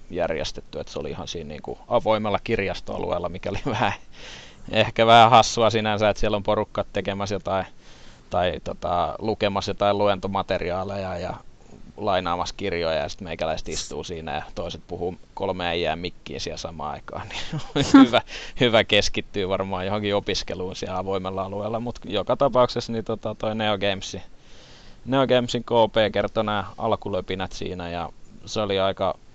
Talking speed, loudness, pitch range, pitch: 150 wpm, -24 LUFS, 95-110 Hz, 100 Hz